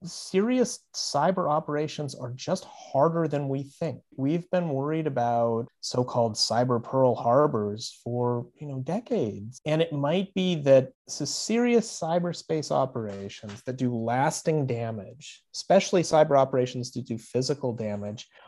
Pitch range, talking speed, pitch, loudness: 120-165 Hz, 130 wpm, 140 Hz, -27 LUFS